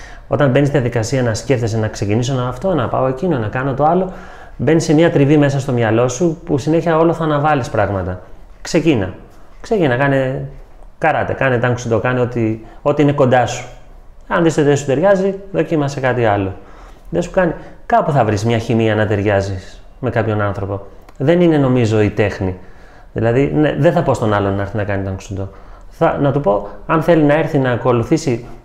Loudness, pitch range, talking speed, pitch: -16 LUFS, 105-150 Hz, 190 wpm, 125 Hz